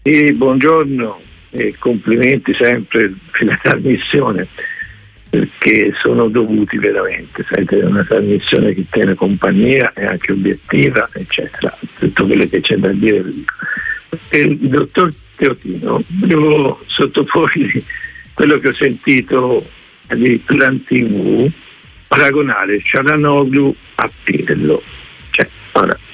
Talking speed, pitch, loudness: 110 wpm, 150 Hz, -13 LUFS